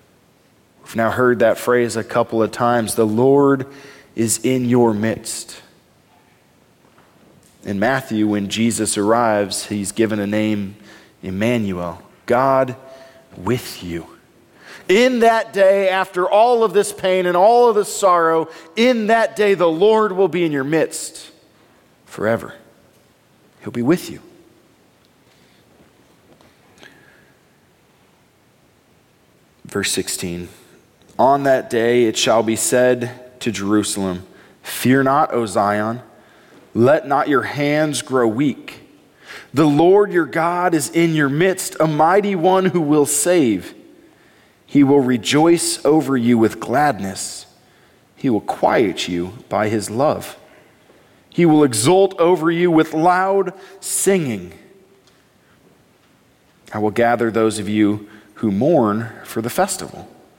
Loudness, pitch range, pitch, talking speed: -17 LUFS, 110-175 Hz, 135 Hz, 125 wpm